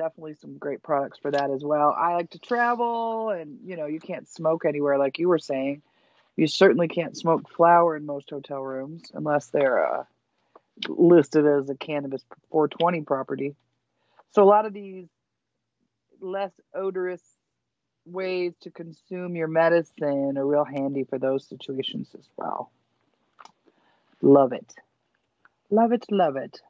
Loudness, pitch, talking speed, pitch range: -24 LUFS, 160 Hz, 150 wpm, 140-180 Hz